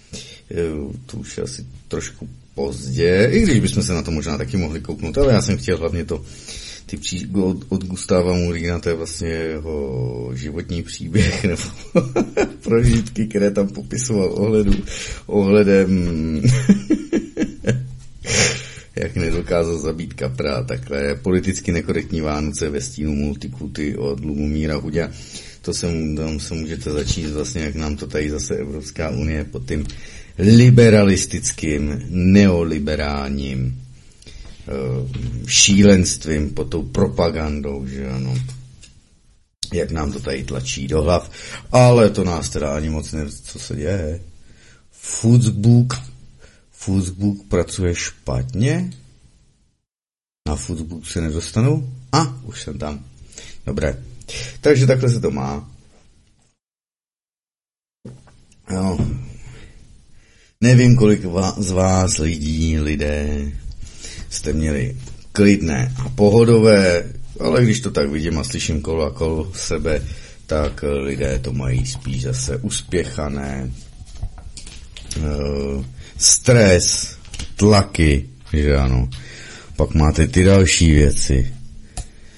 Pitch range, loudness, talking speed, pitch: 70-100 Hz, -19 LUFS, 110 wpm, 80 Hz